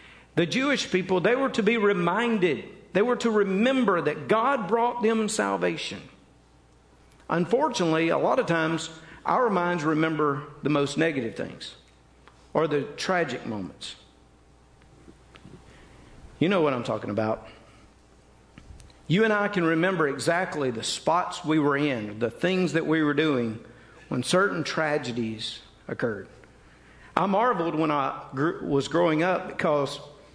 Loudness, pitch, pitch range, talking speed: -25 LUFS, 160 Hz, 120-185 Hz, 135 wpm